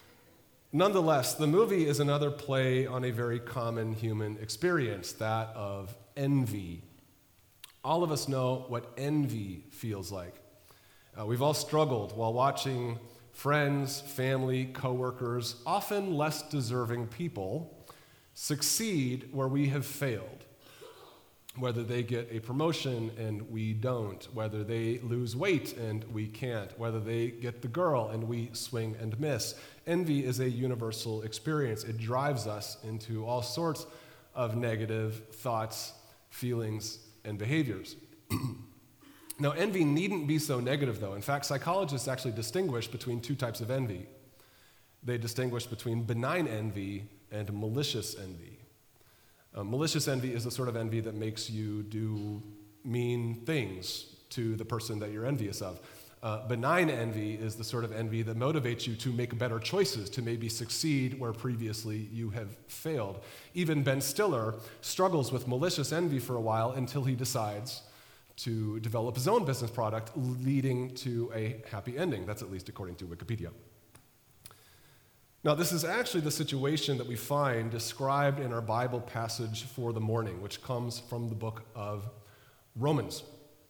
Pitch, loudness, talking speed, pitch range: 120 Hz, -33 LUFS, 150 wpm, 110-140 Hz